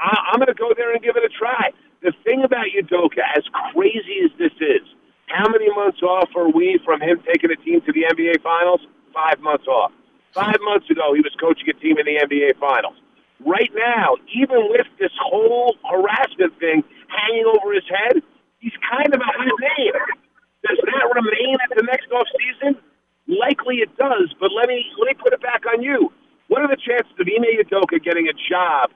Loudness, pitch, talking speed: -18 LUFS, 245 Hz, 205 wpm